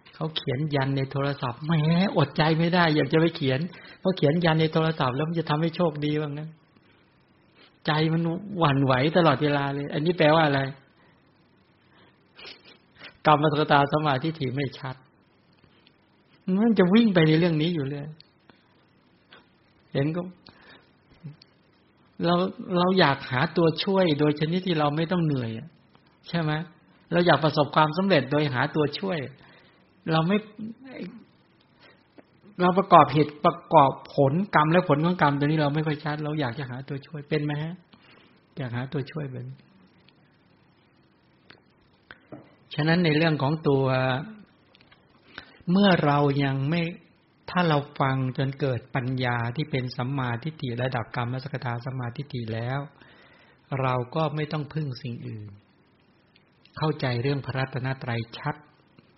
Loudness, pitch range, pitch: -25 LUFS, 135-165 Hz, 150 Hz